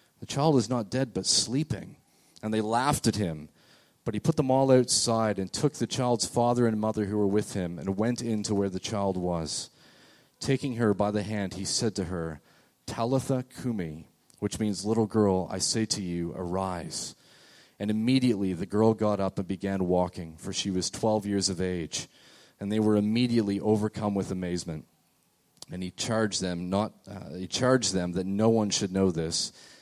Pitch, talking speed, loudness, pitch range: 105 Hz, 190 wpm, -28 LUFS, 95-115 Hz